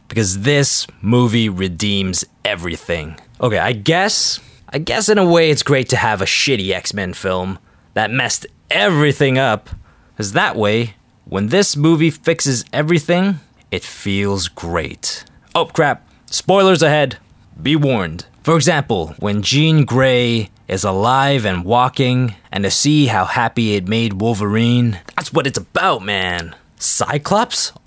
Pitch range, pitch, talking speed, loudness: 100-145 Hz, 120 Hz, 140 wpm, -15 LUFS